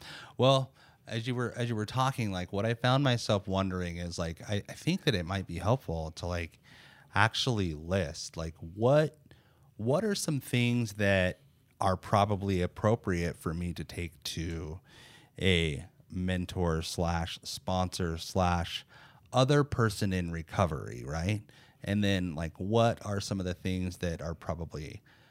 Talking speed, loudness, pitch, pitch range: 155 wpm, -31 LUFS, 100 Hz, 85-120 Hz